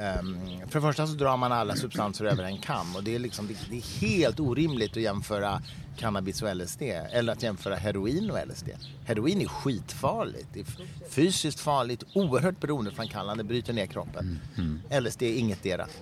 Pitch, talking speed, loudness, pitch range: 115 Hz, 170 wpm, -30 LUFS, 100-140 Hz